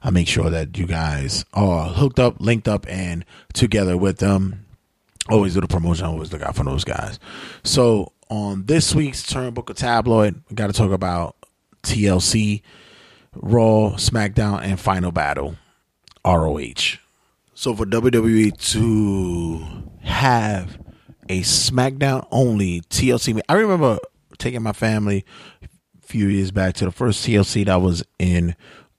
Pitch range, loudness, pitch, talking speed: 90-115 Hz, -20 LUFS, 100 Hz, 145 wpm